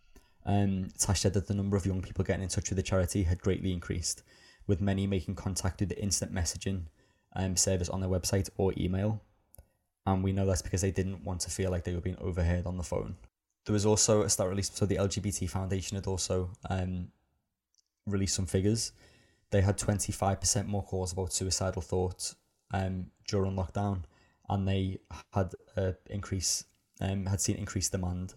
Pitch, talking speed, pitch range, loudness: 95 Hz, 190 wpm, 90-100 Hz, -32 LUFS